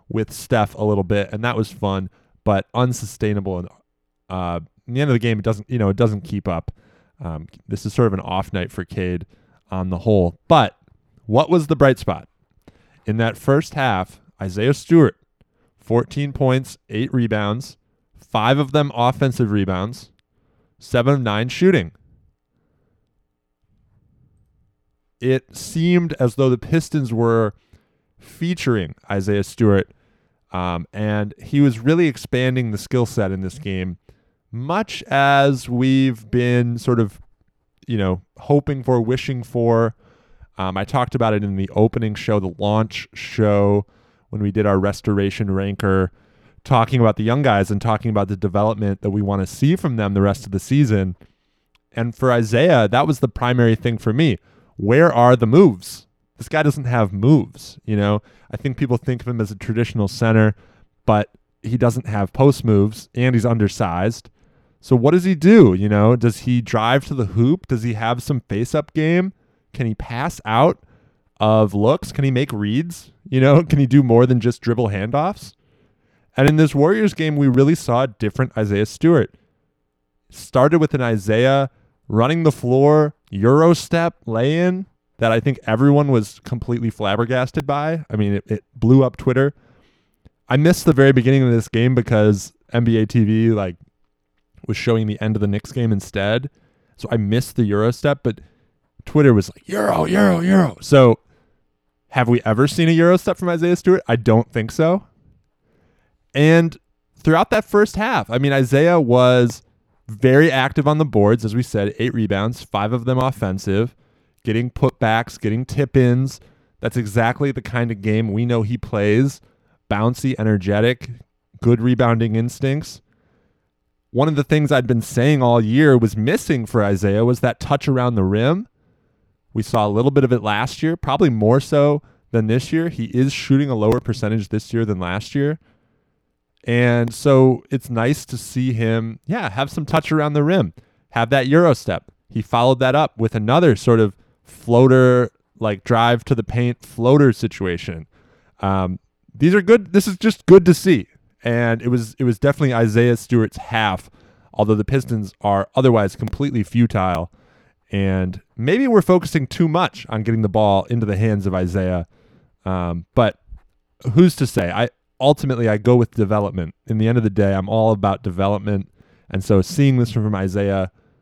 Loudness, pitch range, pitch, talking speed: -18 LUFS, 105-135 Hz, 120 Hz, 170 wpm